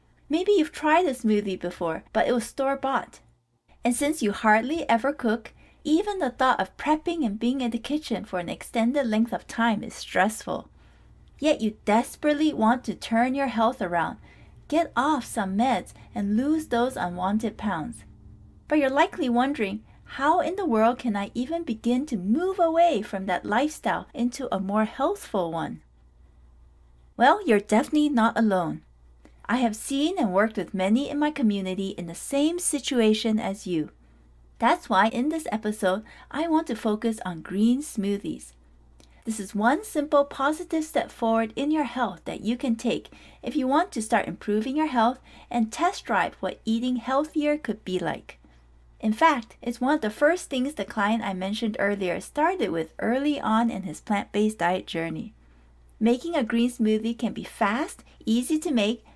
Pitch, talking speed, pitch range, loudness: 230 Hz, 175 wpm, 200-280 Hz, -25 LUFS